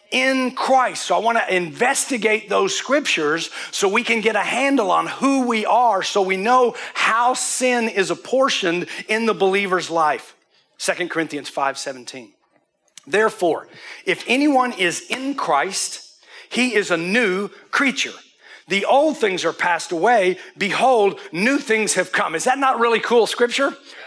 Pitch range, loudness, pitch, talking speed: 180-255 Hz, -19 LUFS, 220 Hz, 155 wpm